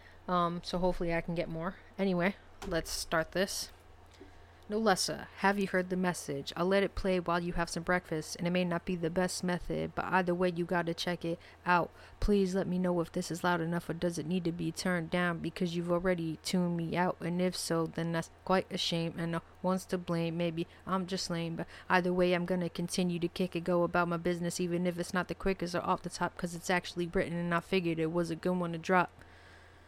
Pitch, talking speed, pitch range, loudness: 175 Hz, 245 wpm, 170-185 Hz, -33 LUFS